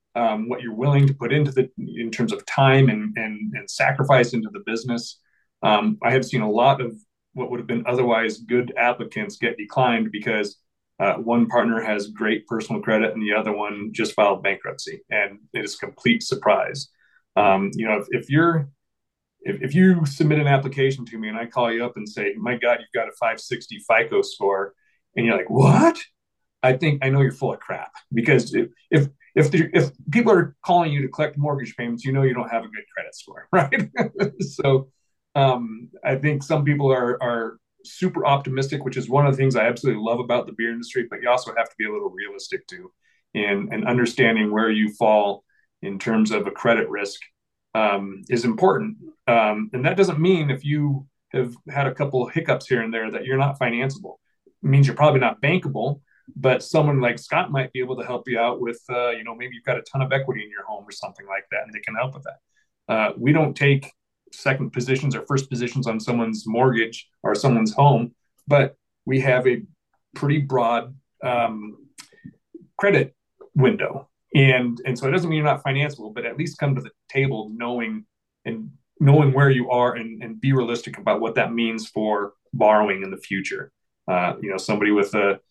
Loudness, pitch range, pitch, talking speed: -21 LUFS, 115-140 Hz, 125 Hz, 205 wpm